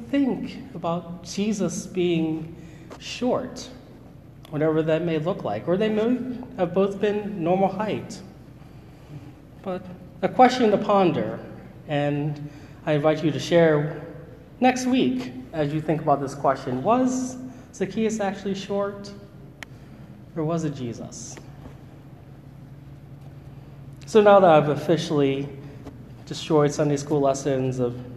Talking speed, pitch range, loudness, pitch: 115 wpm, 140-195 Hz, -23 LUFS, 155 Hz